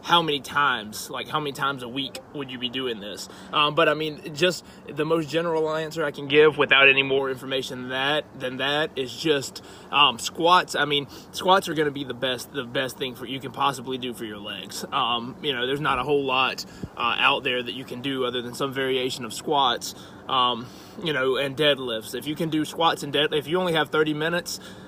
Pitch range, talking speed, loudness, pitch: 125-155 Hz, 235 wpm, -24 LUFS, 140 Hz